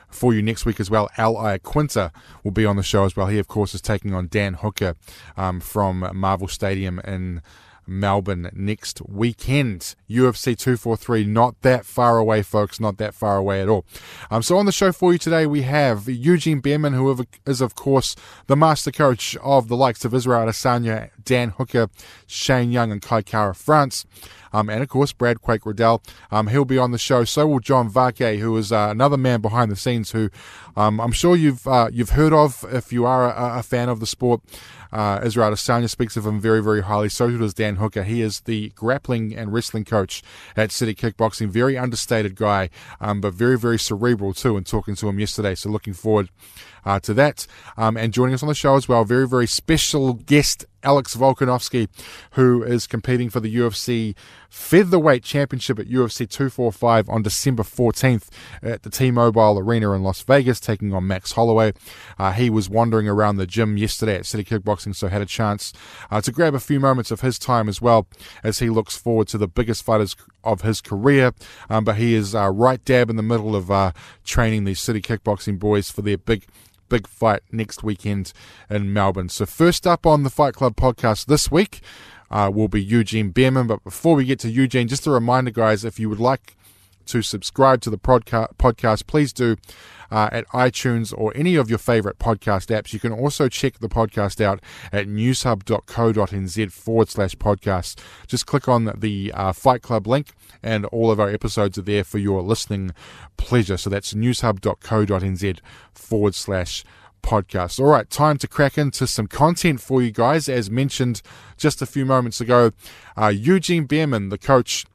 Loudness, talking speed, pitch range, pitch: -20 LUFS, 195 wpm, 105-125 Hz, 115 Hz